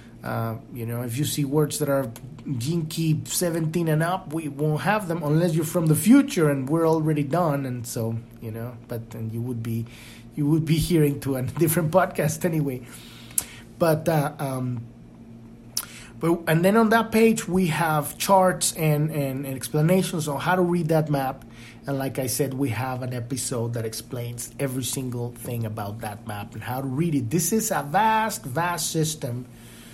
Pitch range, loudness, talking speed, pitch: 120-165 Hz, -24 LUFS, 185 wpm, 140 Hz